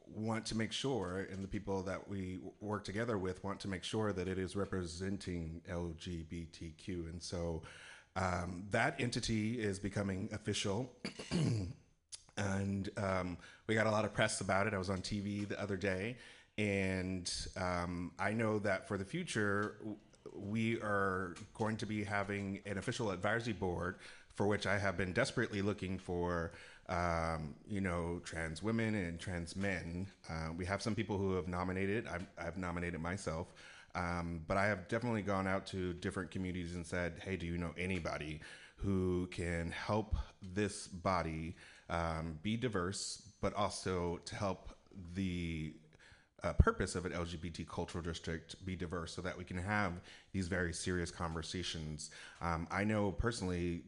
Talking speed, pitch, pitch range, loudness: 160 wpm, 95 Hz, 85-105 Hz, -39 LUFS